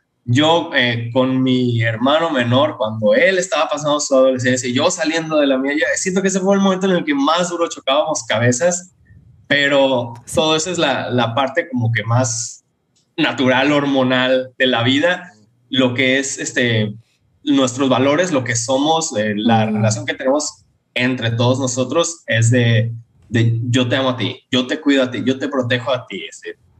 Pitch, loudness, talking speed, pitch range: 130 Hz, -16 LUFS, 180 wpm, 120-150 Hz